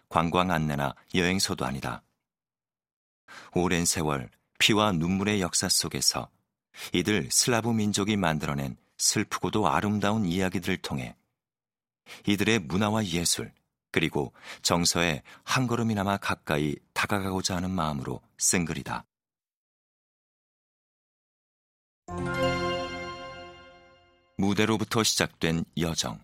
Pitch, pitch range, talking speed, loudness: 90 Hz, 80-100 Hz, 230 characters per minute, -27 LUFS